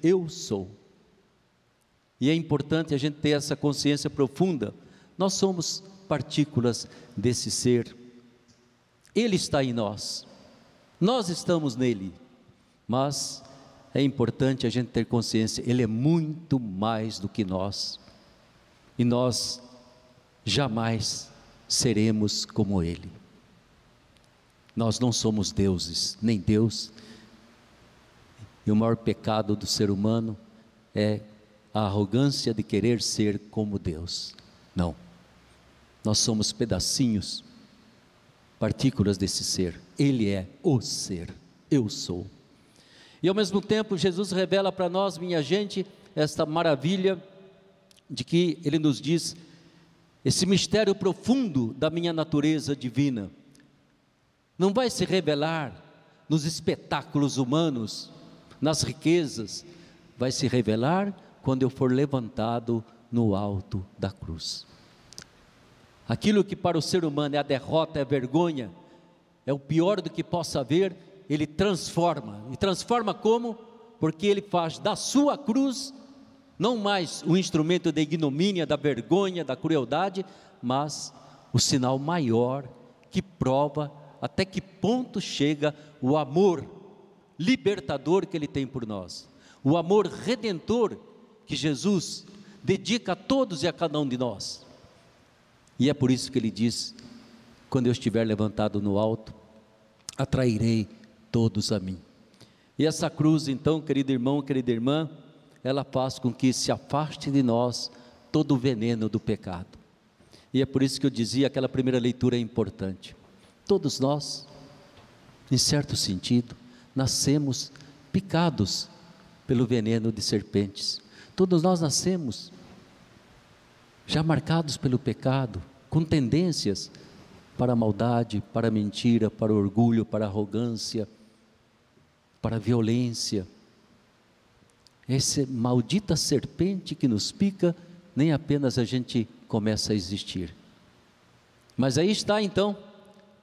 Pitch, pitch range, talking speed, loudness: 135 Hz, 115-165 Hz, 125 wpm, -27 LUFS